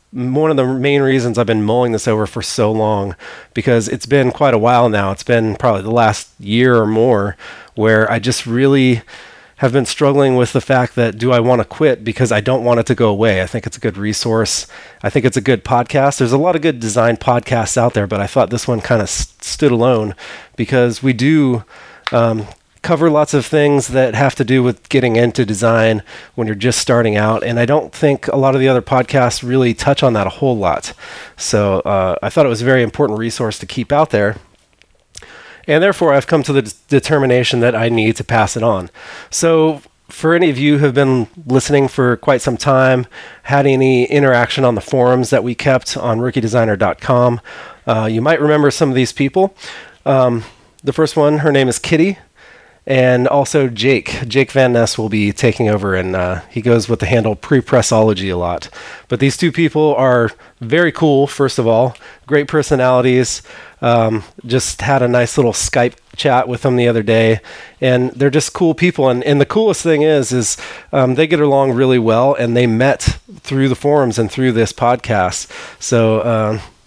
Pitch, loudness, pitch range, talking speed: 125 Hz, -14 LUFS, 115-140 Hz, 205 wpm